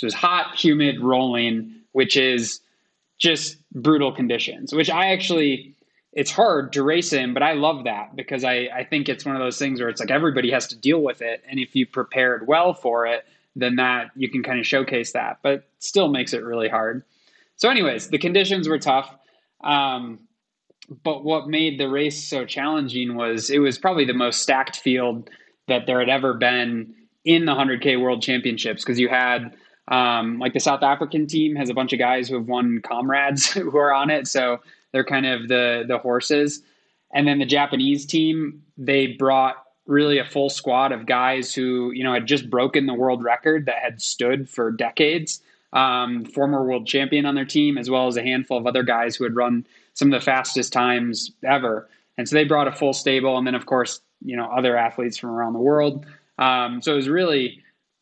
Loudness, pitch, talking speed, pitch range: -21 LUFS, 130 Hz, 205 wpm, 125-145 Hz